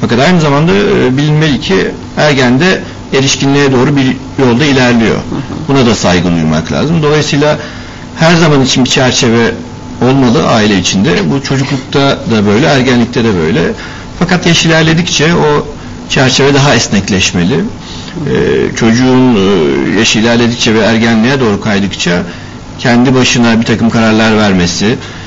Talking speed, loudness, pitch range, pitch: 125 wpm, -8 LUFS, 115-140 Hz, 125 Hz